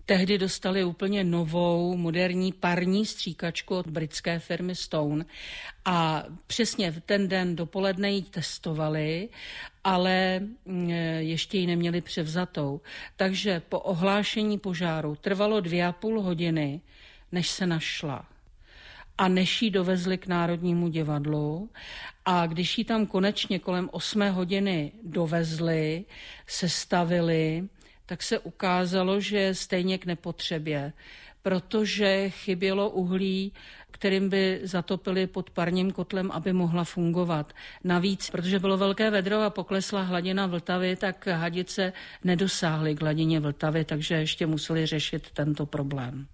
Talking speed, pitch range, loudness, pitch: 120 wpm, 165-195 Hz, -28 LUFS, 180 Hz